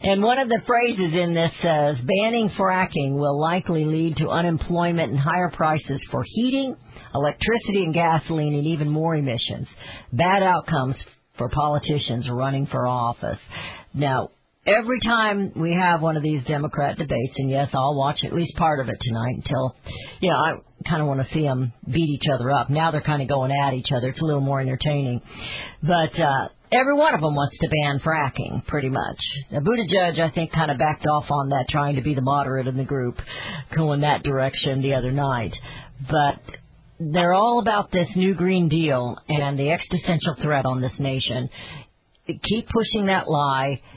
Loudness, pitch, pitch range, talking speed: -22 LUFS, 150 Hz, 135-170 Hz, 185 wpm